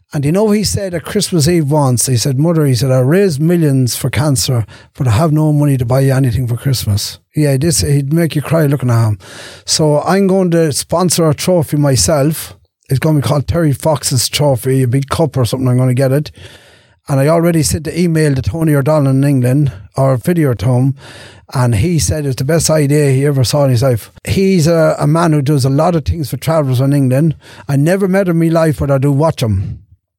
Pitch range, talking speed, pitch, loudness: 130-160 Hz, 235 wpm, 140 Hz, -13 LUFS